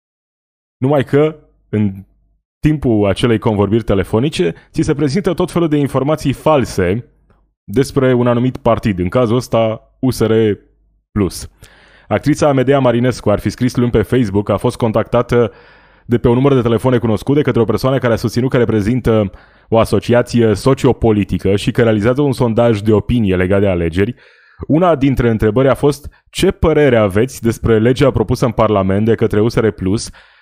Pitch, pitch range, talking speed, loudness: 120 Hz, 105-130 Hz, 160 wpm, -14 LUFS